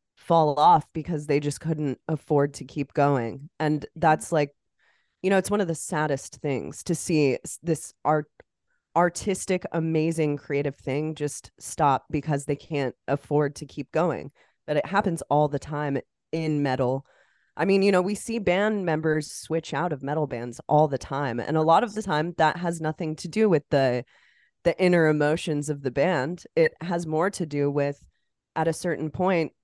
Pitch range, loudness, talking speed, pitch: 145-170 Hz, -25 LUFS, 185 wpm, 155 Hz